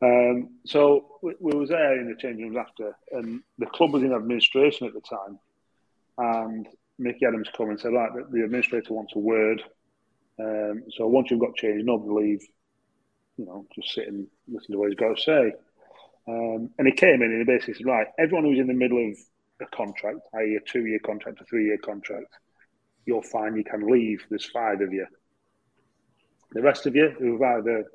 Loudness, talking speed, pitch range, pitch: -25 LUFS, 200 wpm, 110-125 Hz, 115 Hz